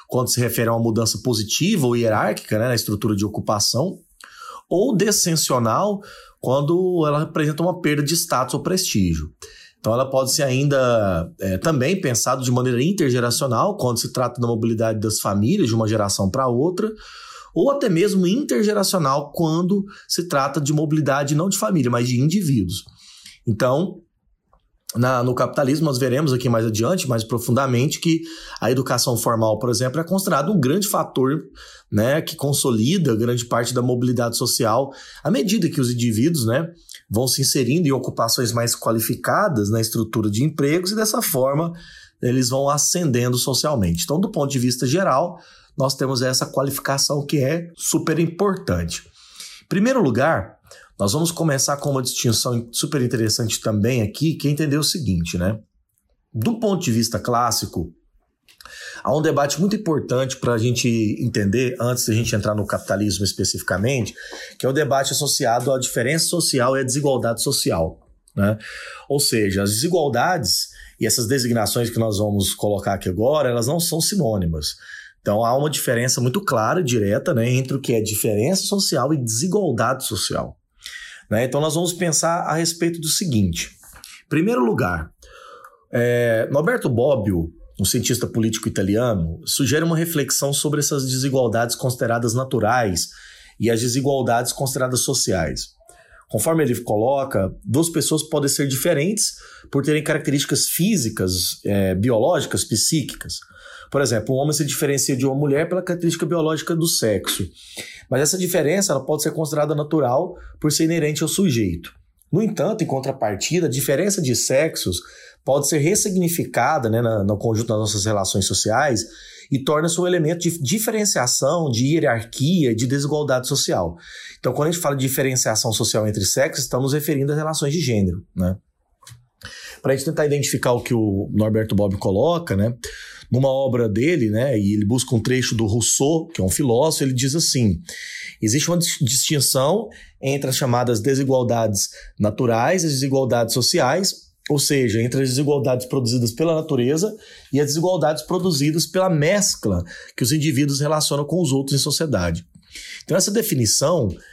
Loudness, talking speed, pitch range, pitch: -20 LUFS, 160 wpm, 115-155 Hz, 135 Hz